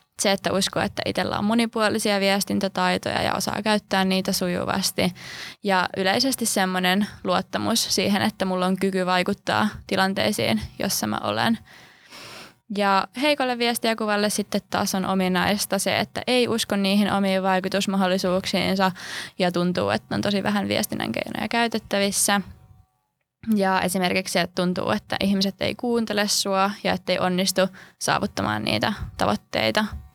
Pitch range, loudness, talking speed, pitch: 185-205 Hz, -23 LUFS, 130 wpm, 195 Hz